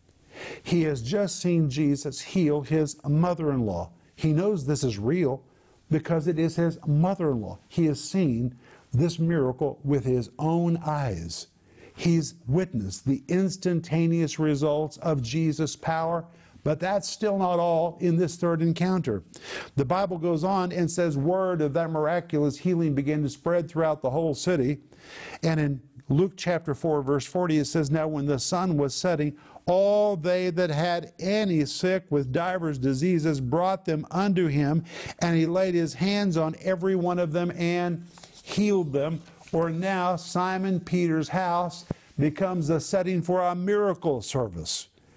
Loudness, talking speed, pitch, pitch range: -26 LUFS, 155 wpm, 165 Hz, 150-180 Hz